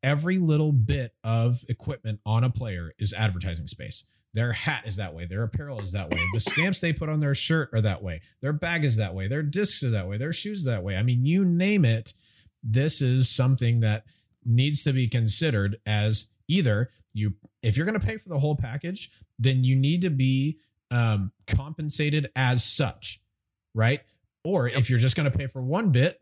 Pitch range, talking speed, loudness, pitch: 105-145 Hz, 210 wpm, -25 LUFS, 125 Hz